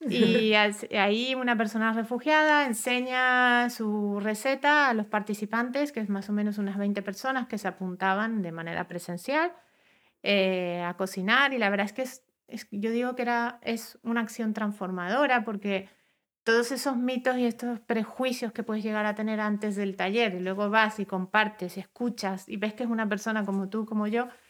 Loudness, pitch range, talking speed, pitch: -27 LUFS, 205-245 Hz, 185 wpm, 220 Hz